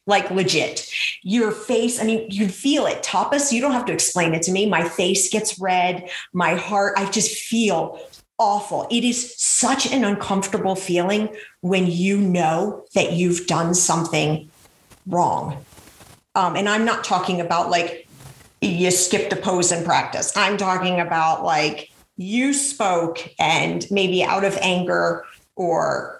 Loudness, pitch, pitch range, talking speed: -20 LUFS, 190 Hz, 175-210 Hz, 155 wpm